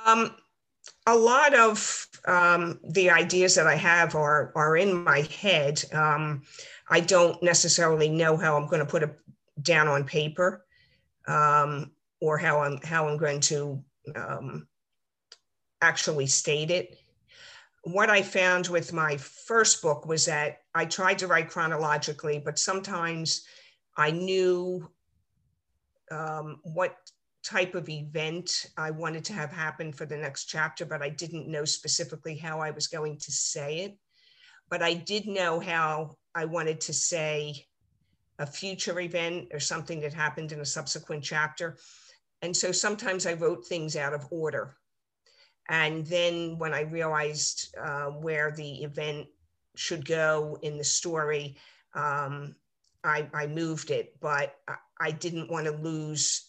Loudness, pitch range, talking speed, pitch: -27 LUFS, 150-175 Hz, 150 wpm, 160 Hz